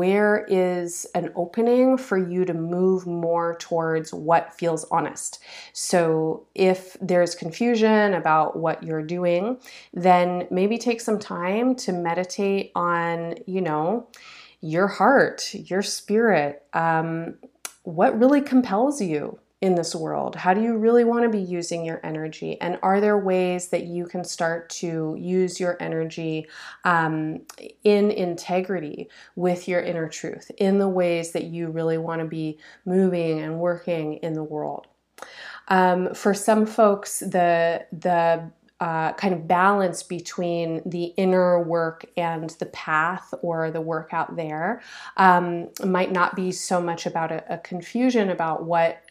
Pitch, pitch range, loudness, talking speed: 175 Hz, 165-195 Hz, -23 LUFS, 150 wpm